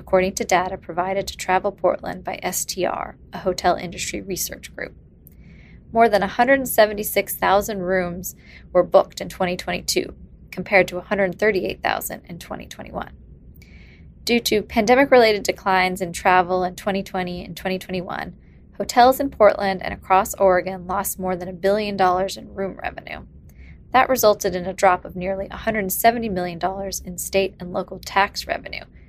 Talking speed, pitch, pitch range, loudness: 140 wpm, 190 Hz, 180-205 Hz, -21 LUFS